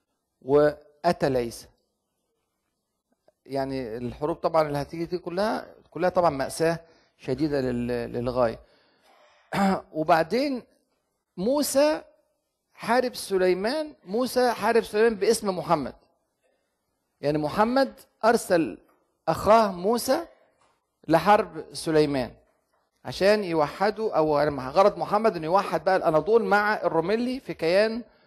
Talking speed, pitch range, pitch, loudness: 90 wpm, 155-225 Hz, 180 Hz, -25 LUFS